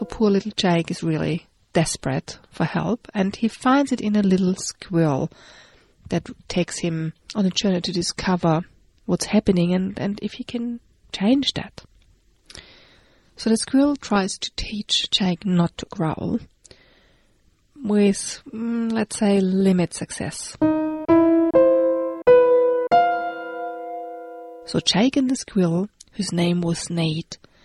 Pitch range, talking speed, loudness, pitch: 175-235 Hz, 125 wpm, -21 LUFS, 195 Hz